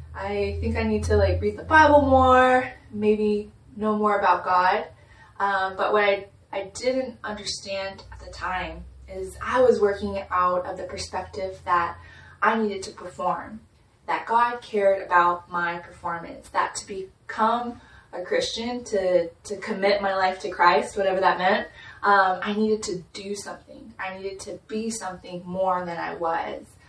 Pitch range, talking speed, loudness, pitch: 175-215 Hz, 165 wpm, -24 LUFS, 195 Hz